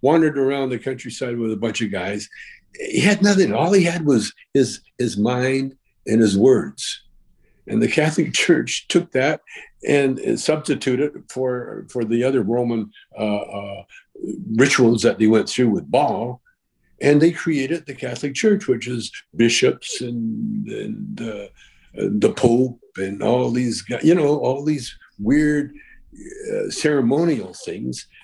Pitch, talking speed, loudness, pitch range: 130 Hz, 150 wpm, -20 LUFS, 115-165 Hz